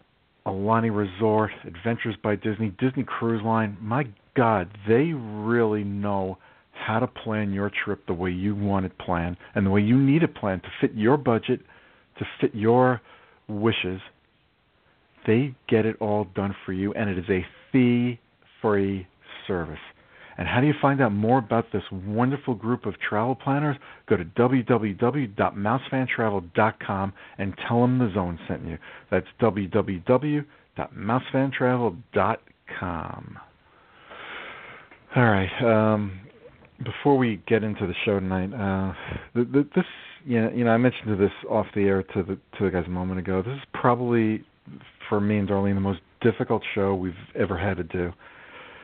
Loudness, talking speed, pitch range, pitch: -25 LUFS, 155 wpm, 100-125 Hz, 110 Hz